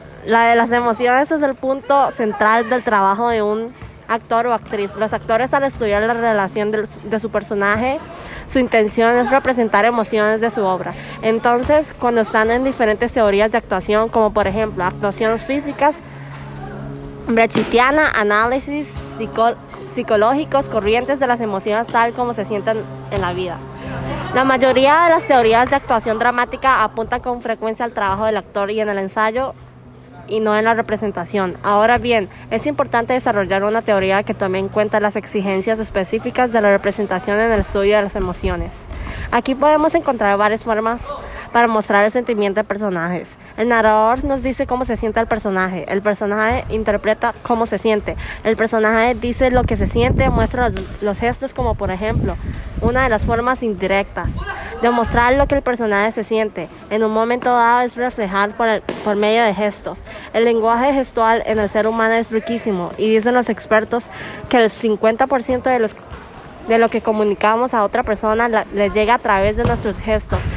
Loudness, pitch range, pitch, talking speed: -17 LUFS, 210-240 Hz, 225 Hz, 175 wpm